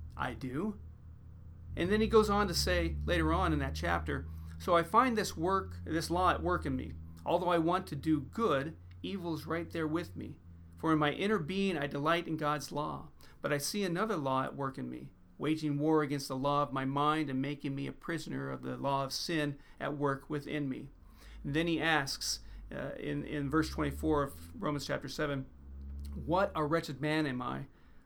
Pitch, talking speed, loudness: 140 Hz, 205 wpm, -34 LUFS